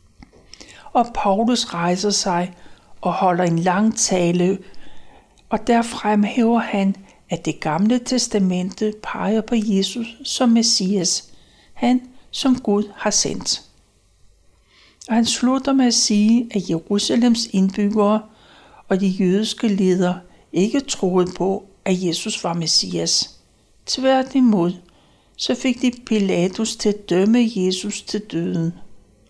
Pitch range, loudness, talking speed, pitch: 180-230 Hz, -19 LUFS, 120 wpm, 205 Hz